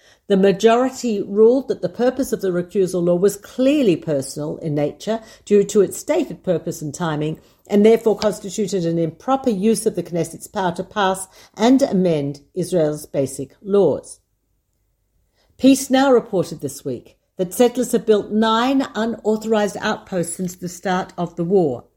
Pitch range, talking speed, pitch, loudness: 170-220 Hz, 155 wpm, 195 Hz, -19 LUFS